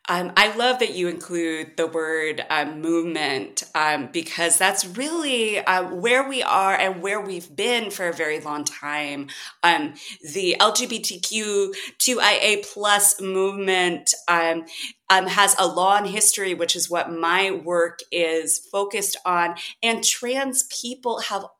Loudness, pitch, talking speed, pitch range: -21 LUFS, 190 Hz, 140 wpm, 170-210 Hz